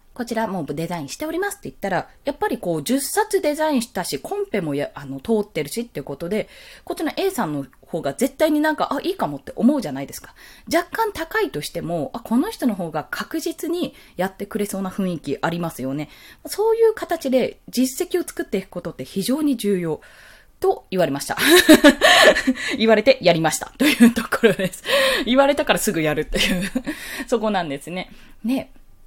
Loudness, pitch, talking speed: -20 LUFS, 240 Hz, 390 characters per minute